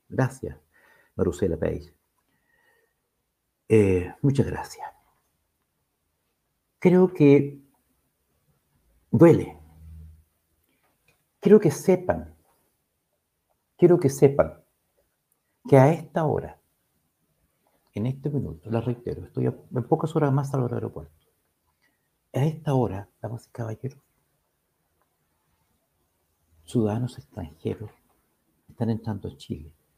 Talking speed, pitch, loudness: 85 wpm, 115 Hz, -23 LUFS